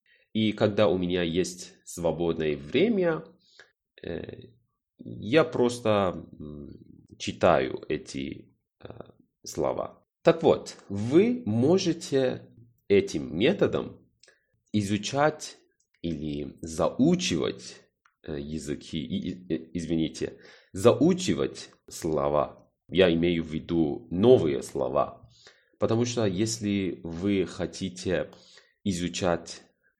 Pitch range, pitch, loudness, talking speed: 80-115 Hz, 95 Hz, -27 LUFS, 75 wpm